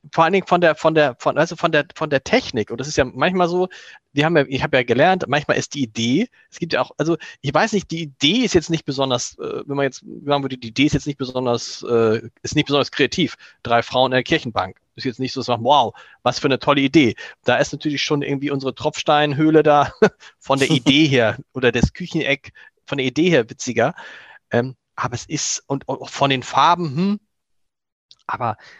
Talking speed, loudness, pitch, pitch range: 225 wpm, -19 LUFS, 140 Hz, 130-155 Hz